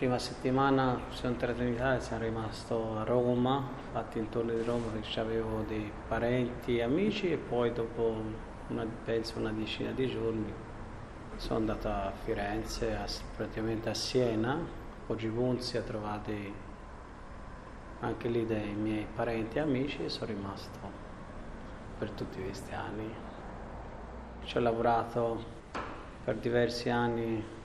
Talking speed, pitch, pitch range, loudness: 135 wpm, 115 Hz, 110-120 Hz, -34 LUFS